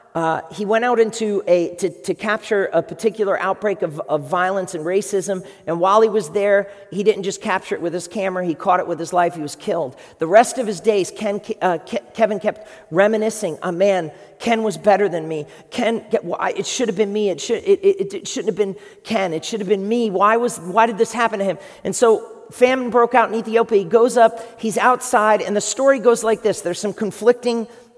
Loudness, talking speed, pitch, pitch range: -19 LUFS, 240 wpm, 210 Hz, 190-230 Hz